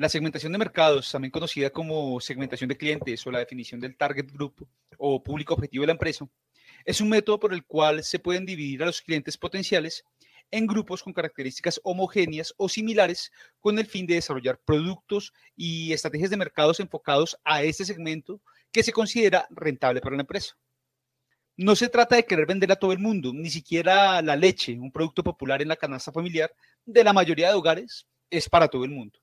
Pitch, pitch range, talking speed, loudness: 160 Hz, 140-190 Hz, 195 wpm, -25 LUFS